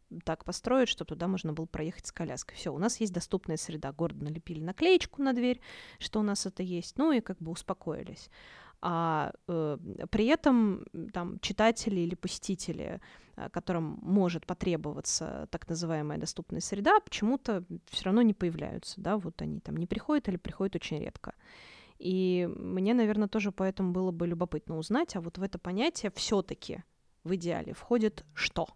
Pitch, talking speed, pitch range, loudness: 185 Hz, 165 wpm, 170-215 Hz, -32 LUFS